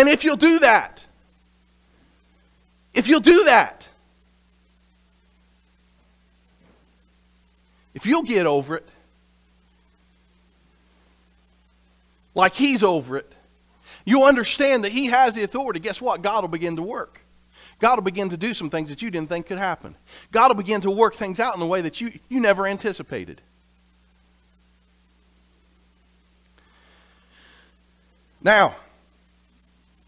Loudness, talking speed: -20 LUFS, 120 wpm